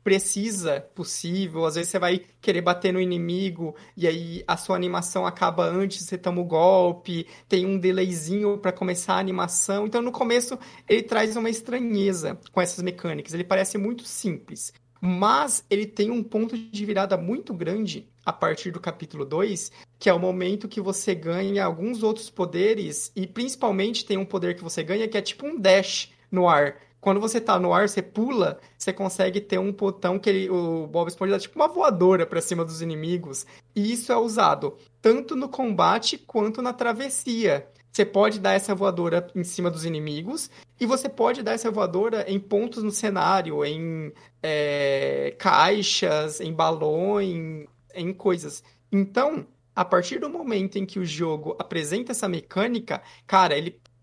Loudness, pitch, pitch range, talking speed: -25 LUFS, 190 Hz, 170-215 Hz, 175 wpm